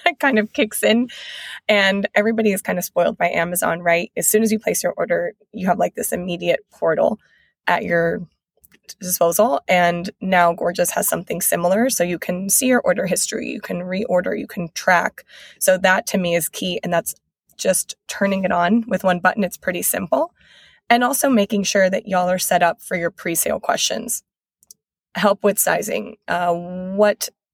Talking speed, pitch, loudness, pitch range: 185 wpm, 190 Hz, -19 LUFS, 175-215 Hz